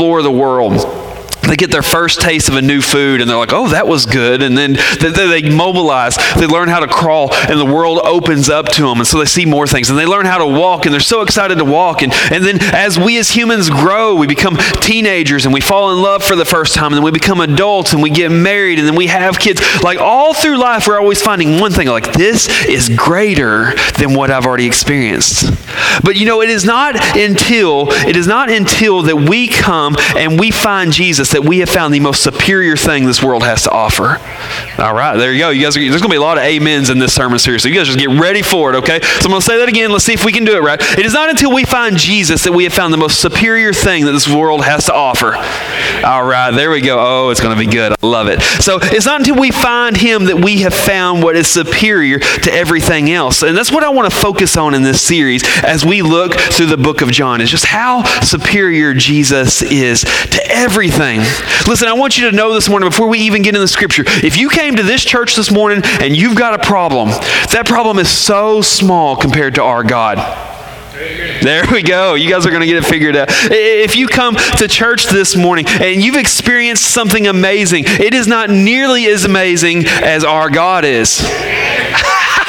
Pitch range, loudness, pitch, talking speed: 150-210 Hz, -9 LUFS, 175 Hz, 240 wpm